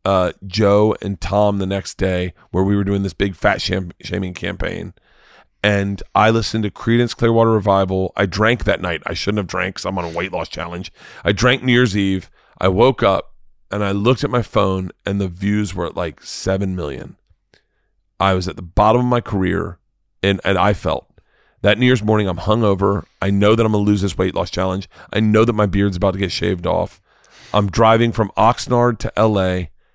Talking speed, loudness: 210 wpm, -18 LUFS